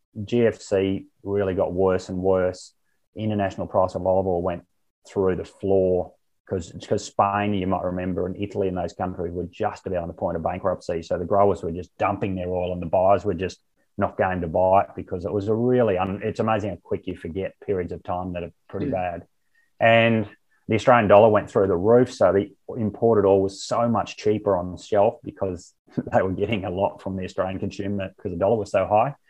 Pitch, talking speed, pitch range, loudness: 95 Hz, 215 wpm, 90-105 Hz, -23 LUFS